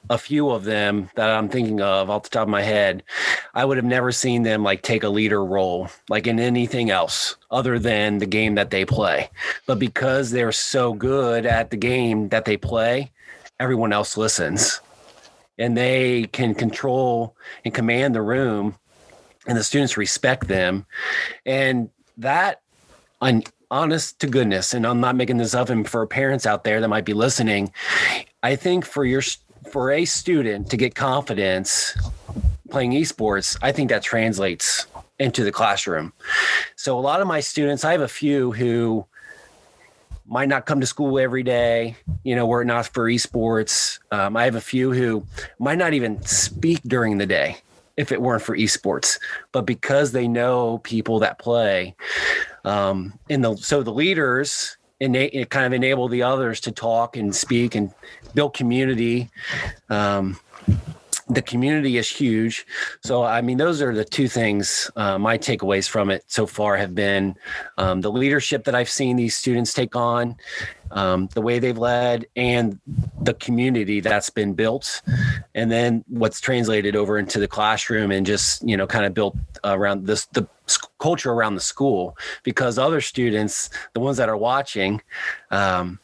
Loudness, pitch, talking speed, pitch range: -21 LUFS, 115 Hz, 175 wpm, 105-125 Hz